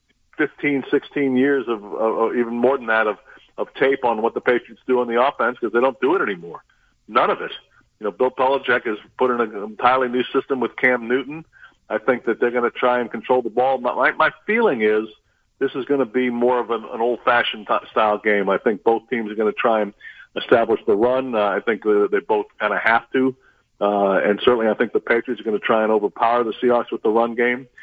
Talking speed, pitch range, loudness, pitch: 240 wpm, 115-130 Hz, -20 LUFS, 125 Hz